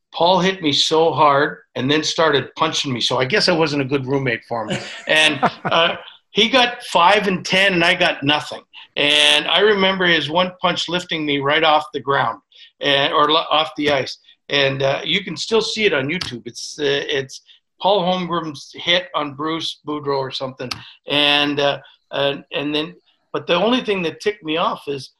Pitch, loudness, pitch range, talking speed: 155 Hz, -17 LUFS, 140-185 Hz, 195 wpm